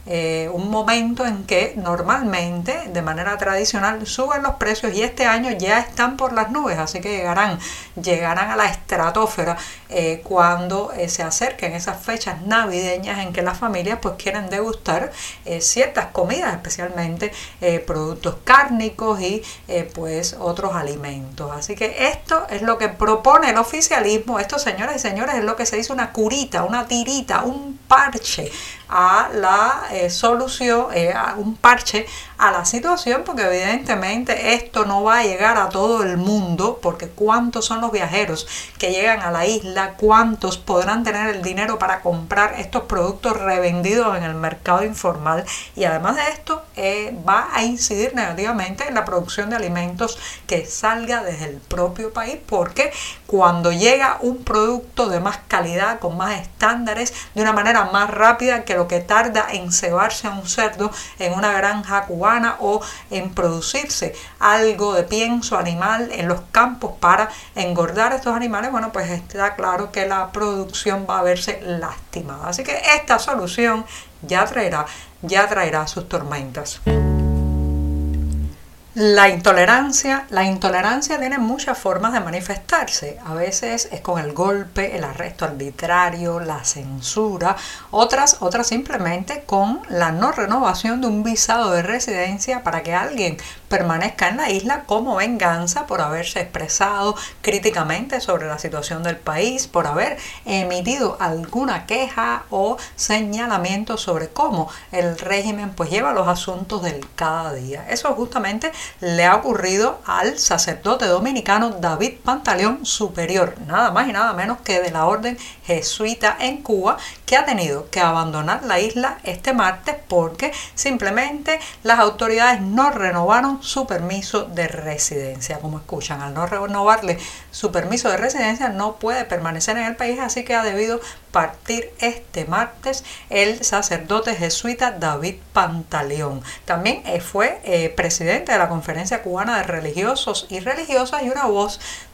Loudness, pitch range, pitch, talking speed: -19 LUFS, 175-235 Hz, 205 Hz, 150 wpm